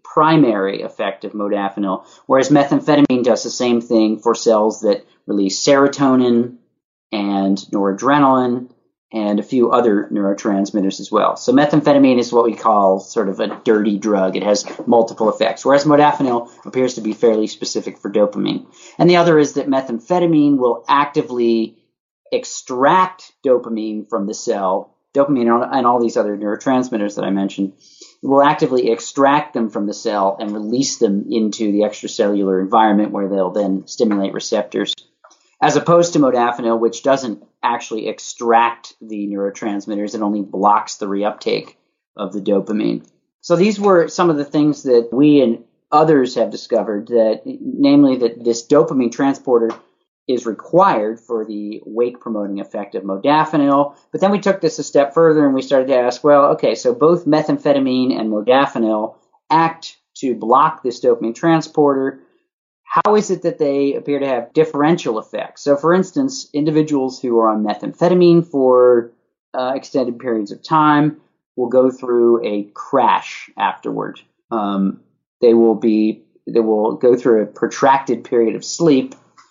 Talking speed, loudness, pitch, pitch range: 155 wpm, -16 LUFS, 120 Hz, 105-145 Hz